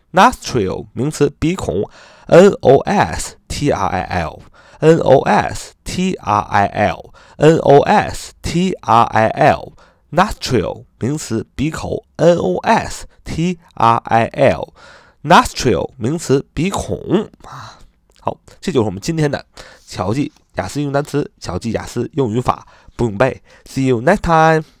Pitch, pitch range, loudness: 145 Hz, 120-160 Hz, -16 LUFS